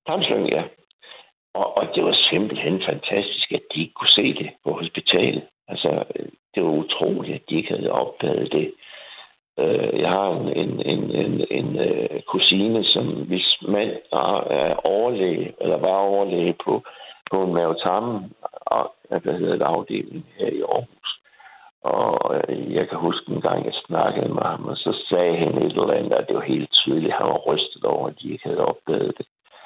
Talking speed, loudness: 180 wpm, -21 LUFS